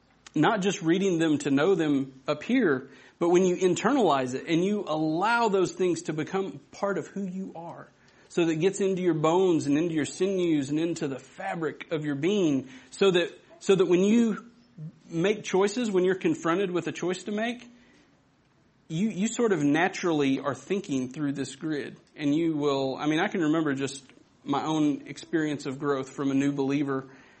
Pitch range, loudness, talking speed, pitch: 145-190 Hz, -27 LUFS, 195 wpm, 165 Hz